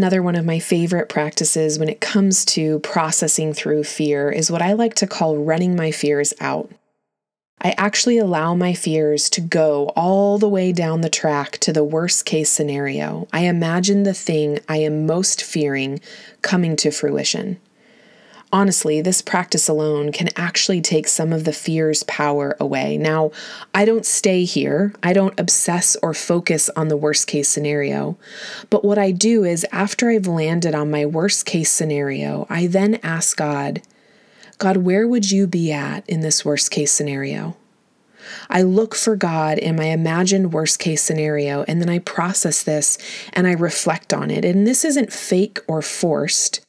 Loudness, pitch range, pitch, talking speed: -18 LUFS, 155-195 Hz, 170 Hz, 170 wpm